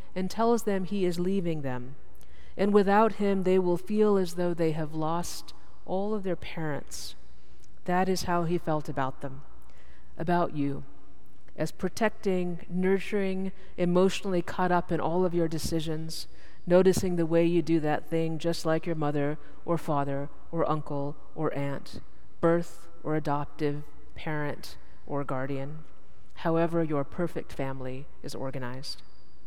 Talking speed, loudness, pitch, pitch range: 145 wpm, -29 LUFS, 165 Hz, 140-180 Hz